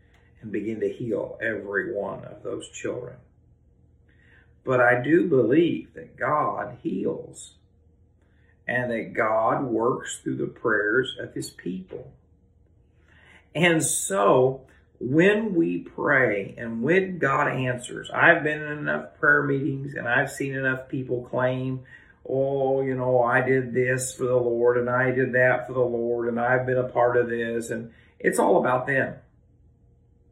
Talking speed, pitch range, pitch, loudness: 150 wpm, 115-140 Hz, 125 Hz, -24 LUFS